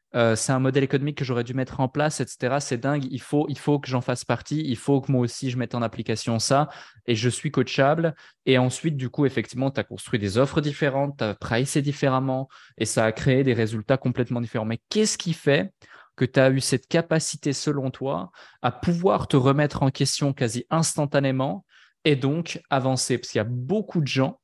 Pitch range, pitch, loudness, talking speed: 125-145 Hz, 135 Hz, -24 LUFS, 215 wpm